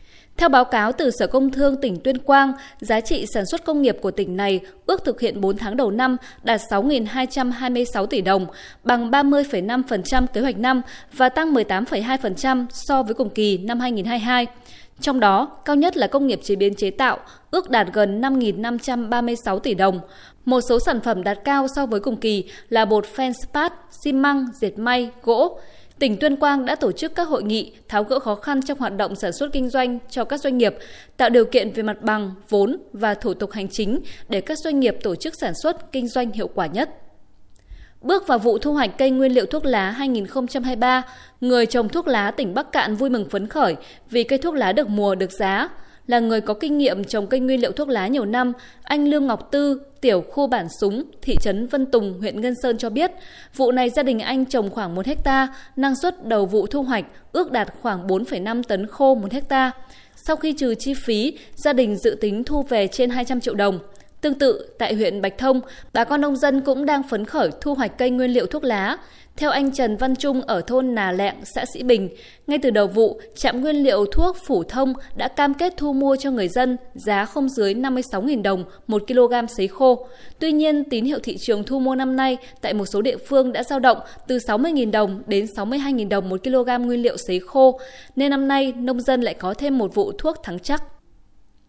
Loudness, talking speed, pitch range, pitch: -21 LUFS, 215 wpm, 215-275 Hz, 250 Hz